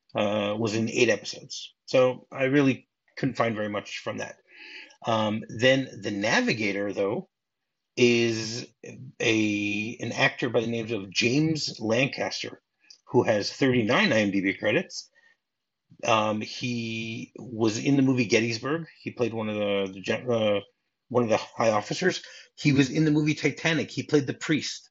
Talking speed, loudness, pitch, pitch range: 150 wpm, -26 LUFS, 120 Hz, 110-140 Hz